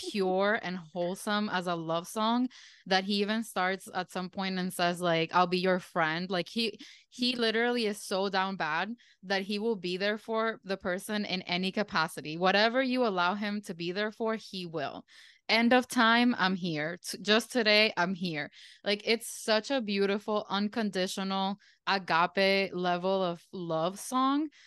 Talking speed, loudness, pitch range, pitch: 175 wpm, -30 LUFS, 180-220 Hz, 195 Hz